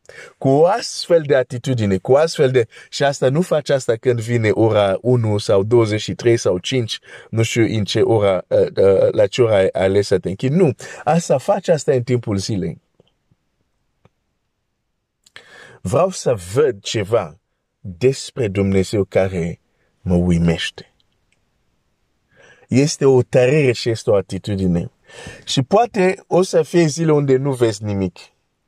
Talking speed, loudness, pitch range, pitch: 140 wpm, -17 LUFS, 100-140 Hz, 120 Hz